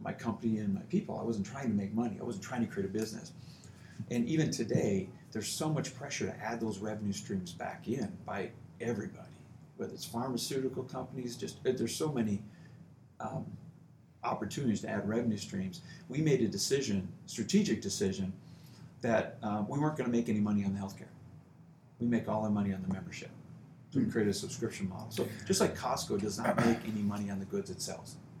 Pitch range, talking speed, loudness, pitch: 100-120 Hz, 195 wpm, -35 LUFS, 110 Hz